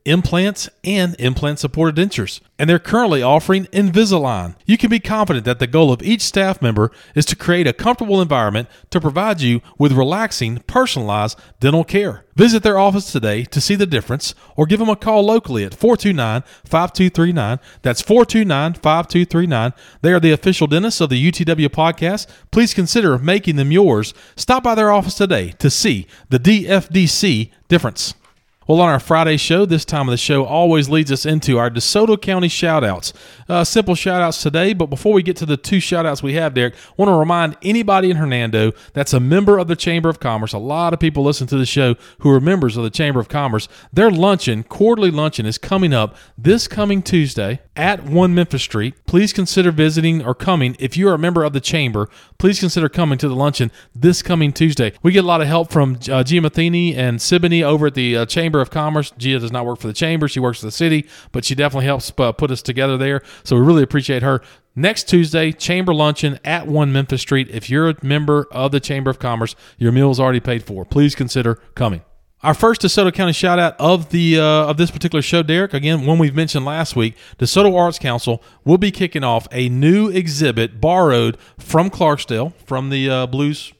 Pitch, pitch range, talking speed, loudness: 155 Hz, 130-180 Hz, 205 wpm, -16 LUFS